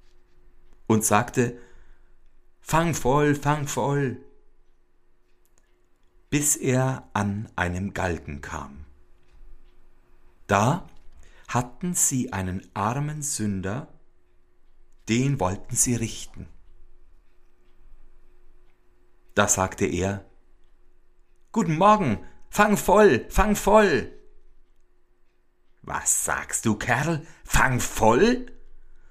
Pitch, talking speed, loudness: 100 Hz, 75 wpm, -23 LUFS